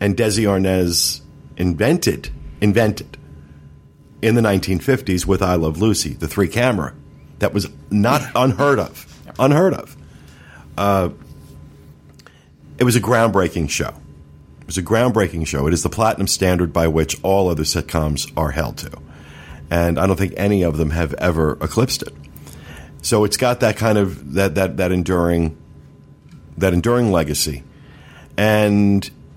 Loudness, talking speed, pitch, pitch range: -18 LUFS, 145 wpm, 90 Hz, 75-105 Hz